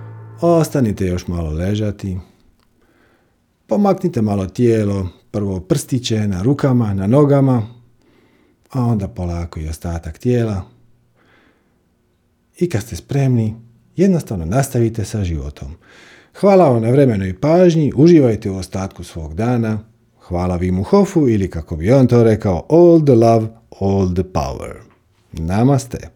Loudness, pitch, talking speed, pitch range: -16 LUFS, 110 Hz, 125 wpm, 95-125 Hz